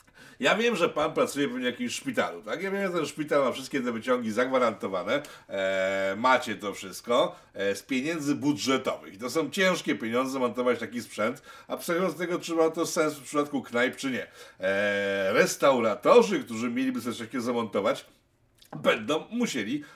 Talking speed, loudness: 170 wpm, -27 LUFS